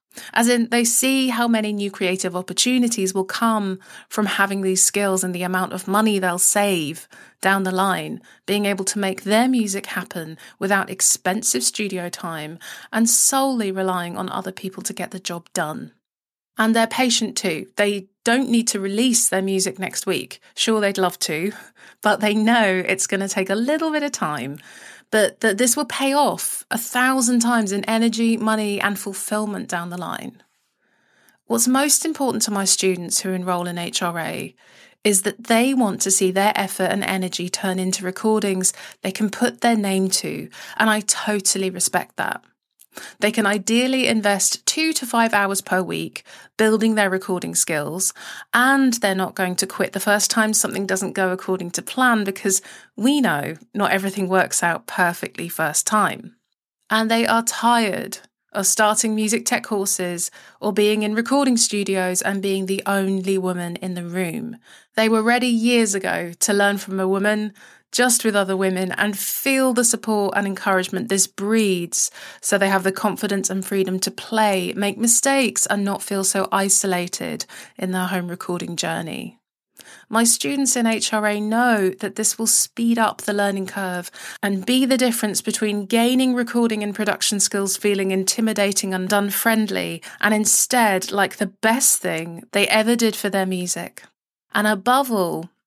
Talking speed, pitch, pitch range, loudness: 170 wpm, 200 Hz, 190-225 Hz, -20 LUFS